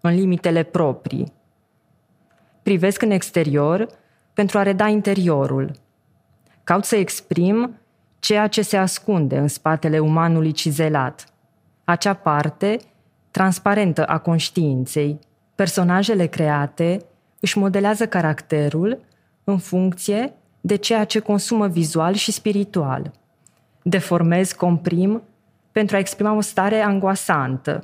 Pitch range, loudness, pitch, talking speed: 160-205 Hz, -20 LUFS, 180 Hz, 105 wpm